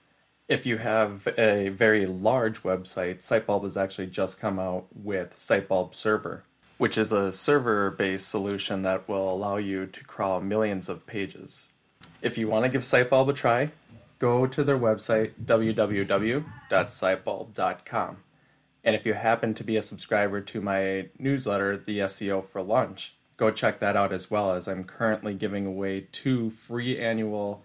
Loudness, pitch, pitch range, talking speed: -27 LUFS, 105 Hz, 95-115 Hz, 160 wpm